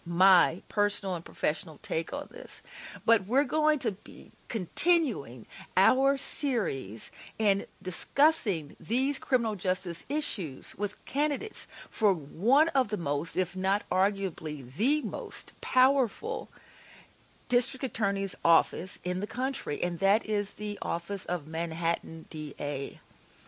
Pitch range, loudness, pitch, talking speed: 180-260 Hz, -29 LUFS, 205 Hz, 125 wpm